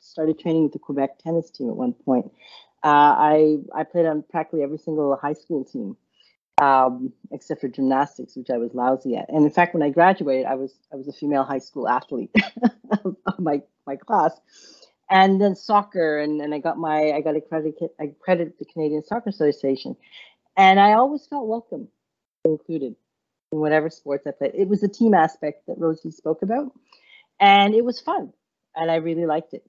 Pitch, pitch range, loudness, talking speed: 160 Hz, 145-190 Hz, -21 LUFS, 195 wpm